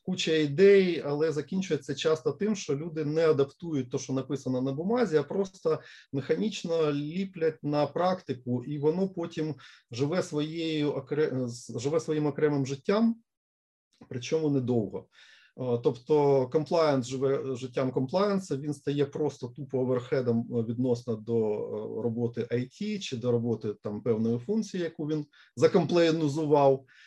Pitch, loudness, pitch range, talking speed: 145 Hz, -29 LUFS, 130-165 Hz, 125 wpm